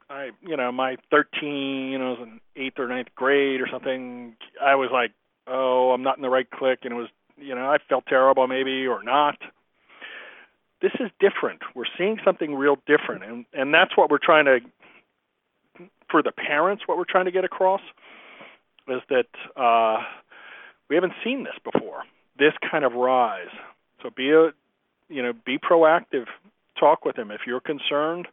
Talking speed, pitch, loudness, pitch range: 180 wpm, 135 Hz, -23 LUFS, 125-155 Hz